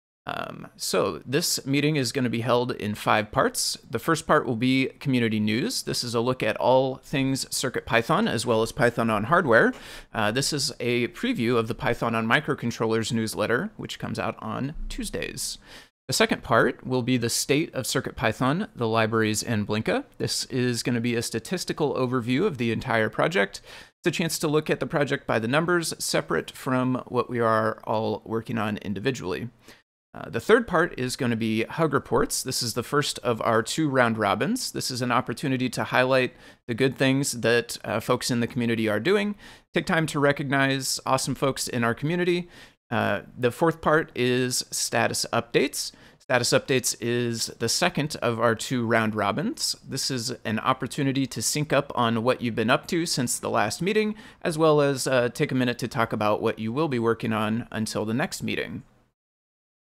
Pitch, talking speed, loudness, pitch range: 125 Hz, 195 wpm, -25 LUFS, 115-140 Hz